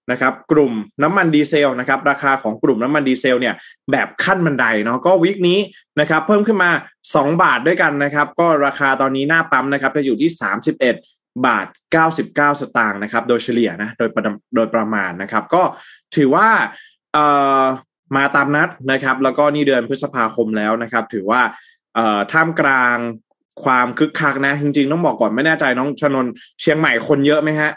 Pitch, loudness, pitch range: 140 Hz, -16 LUFS, 120-150 Hz